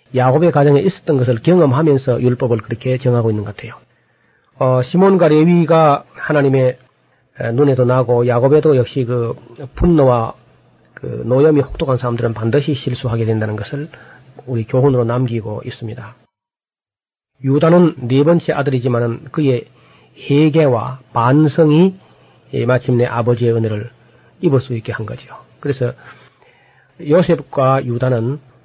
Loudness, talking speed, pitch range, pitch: -15 LUFS, 290 characters per minute, 120-145 Hz, 130 Hz